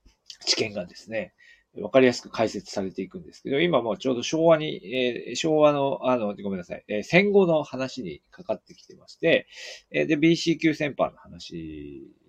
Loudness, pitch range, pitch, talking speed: -24 LUFS, 105-160 Hz, 130 Hz, 355 characters per minute